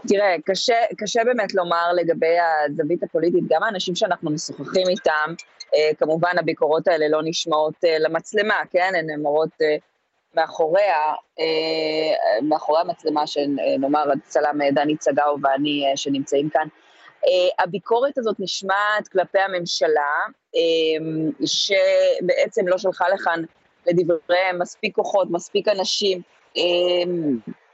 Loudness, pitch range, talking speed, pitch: -21 LUFS, 155-190 Hz, 95 wpm, 170 Hz